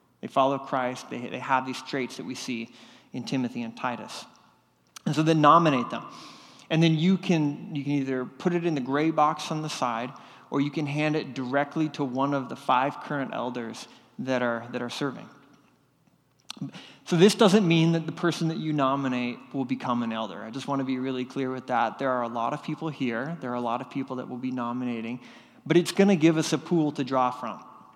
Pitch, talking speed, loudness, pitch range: 135 Hz, 225 wpm, -27 LUFS, 125-155 Hz